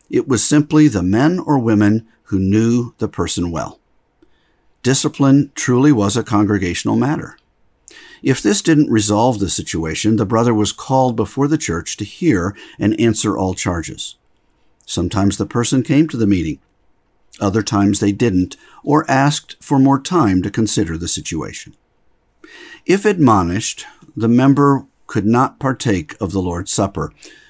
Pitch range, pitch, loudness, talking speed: 100-135 Hz, 110 Hz, -16 LUFS, 150 wpm